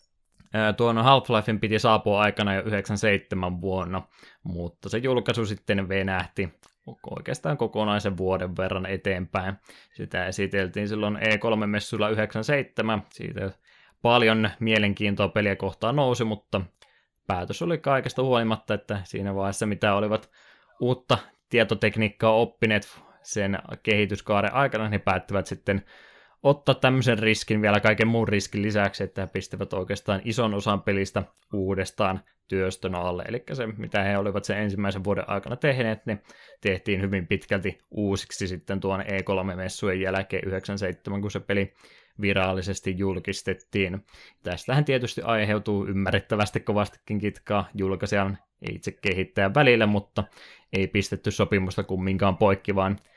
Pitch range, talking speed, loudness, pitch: 95-110 Hz, 125 wpm, -26 LUFS, 100 Hz